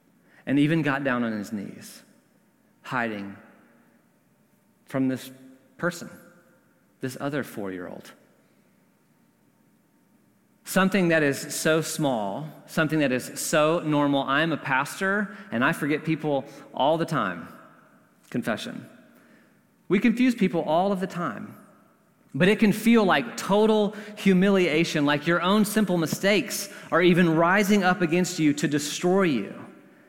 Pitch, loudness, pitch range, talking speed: 175 Hz, -24 LUFS, 145-205 Hz, 130 wpm